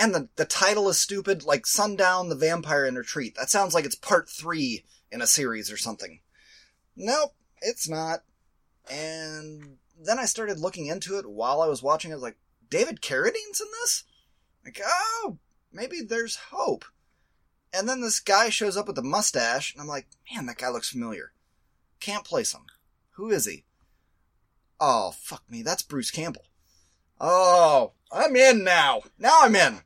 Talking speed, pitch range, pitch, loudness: 170 wpm, 155-230 Hz, 190 Hz, -24 LUFS